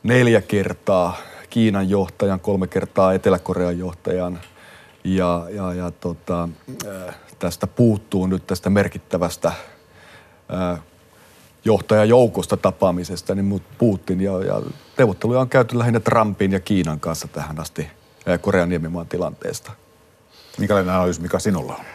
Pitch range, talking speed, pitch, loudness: 90-105 Hz, 120 wpm, 95 Hz, -20 LUFS